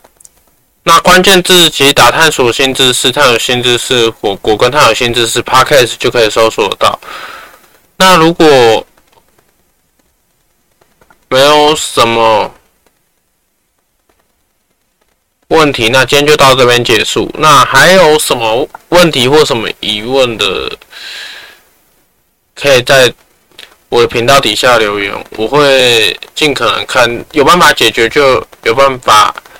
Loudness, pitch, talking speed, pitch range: -7 LUFS, 140 Hz, 190 characters per minute, 120-175 Hz